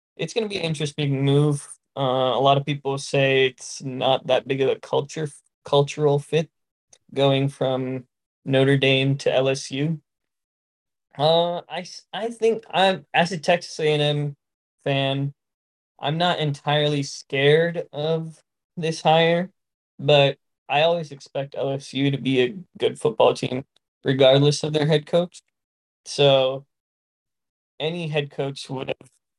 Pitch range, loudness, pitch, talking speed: 135-160 Hz, -22 LUFS, 145 Hz, 135 wpm